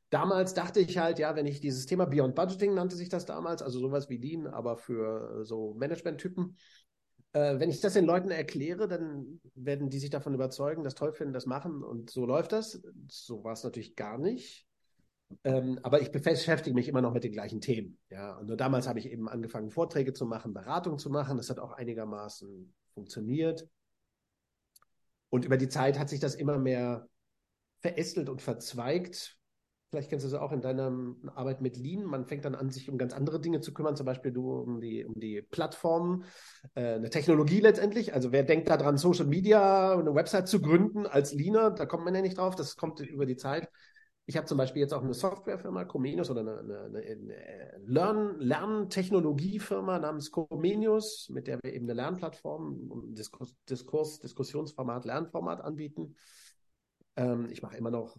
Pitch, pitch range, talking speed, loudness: 145 Hz, 125-170 Hz, 190 wpm, -32 LUFS